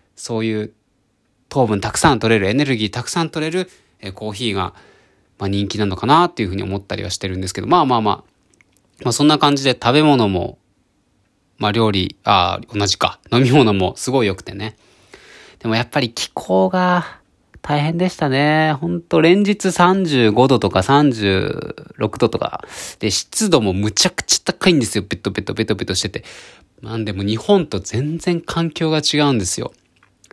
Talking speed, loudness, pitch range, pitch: 340 characters per minute, -17 LUFS, 100-150 Hz, 115 Hz